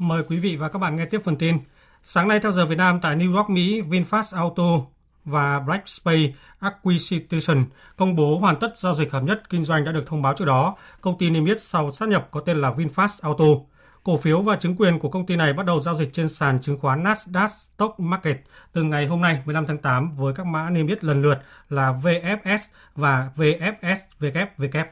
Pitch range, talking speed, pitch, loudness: 150-185 Hz, 220 wpm, 165 Hz, -22 LUFS